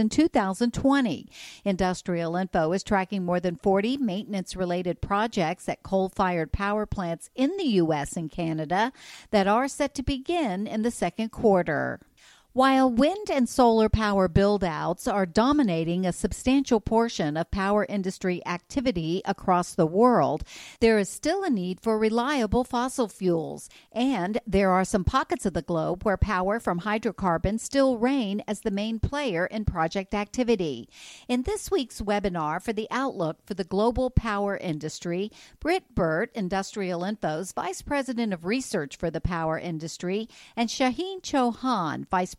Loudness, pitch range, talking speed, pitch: -26 LUFS, 180-245 Hz, 150 wpm, 205 Hz